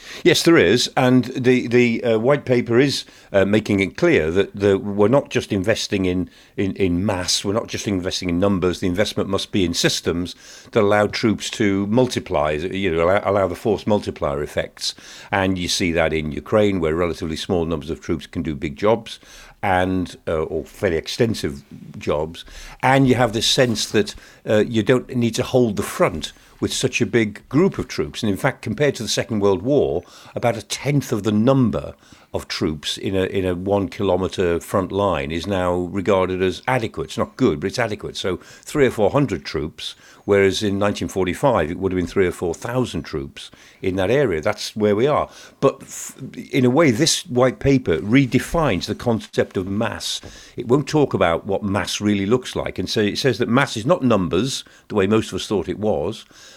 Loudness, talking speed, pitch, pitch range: -20 LUFS, 205 wpm, 105 Hz, 95-125 Hz